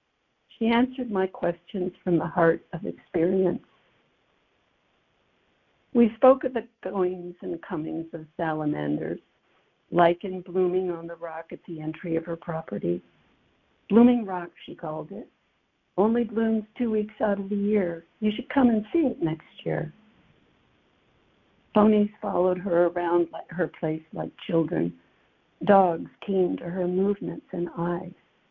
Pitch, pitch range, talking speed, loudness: 180 Hz, 170-210 Hz, 135 wpm, -26 LUFS